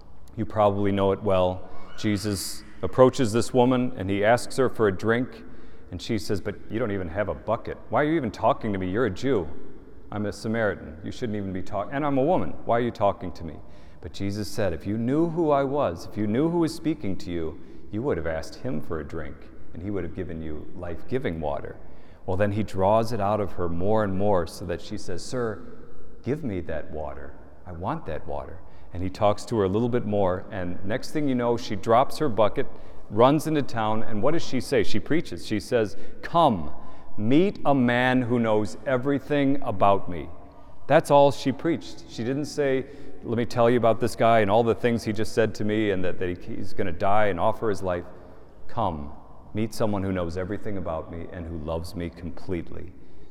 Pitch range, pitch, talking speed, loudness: 90-120 Hz, 105 Hz, 225 wpm, -26 LUFS